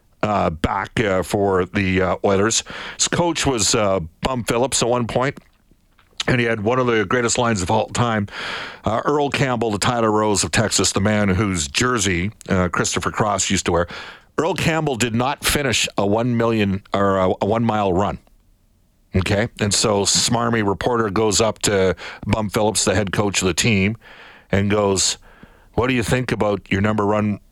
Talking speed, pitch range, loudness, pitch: 185 wpm, 95-115 Hz, -19 LUFS, 105 Hz